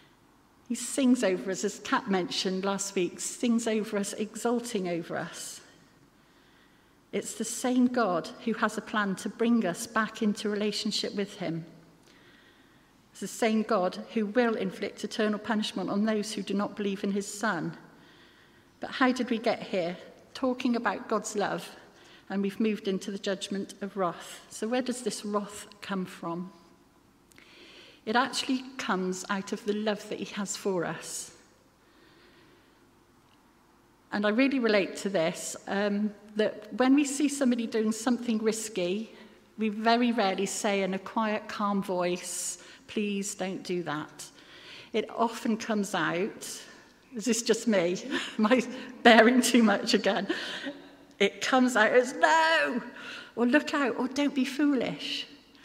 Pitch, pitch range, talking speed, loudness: 215 Hz, 195-240 Hz, 150 wpm, -29 LUFS